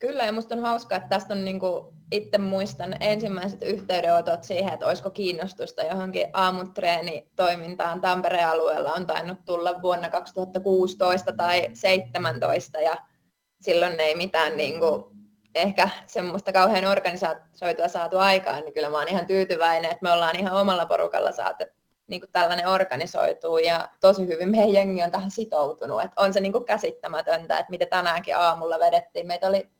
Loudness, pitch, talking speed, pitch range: -24 LUFS, 185 Hz, 160 wpm, 170-195 Hz